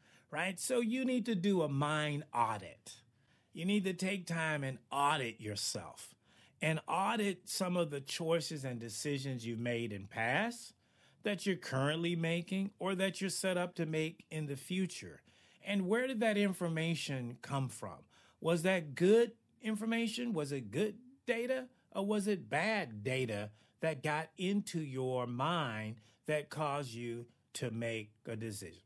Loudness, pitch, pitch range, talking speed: -37 LUFS, 155 Hz, 125-195 Hz, 155 wpm